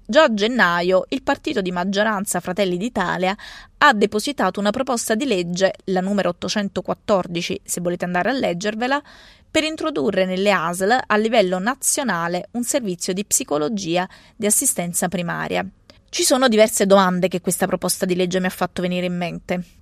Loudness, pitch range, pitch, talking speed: -20 LUFS, 180-220 Hz, 190 Hz, 155 wpm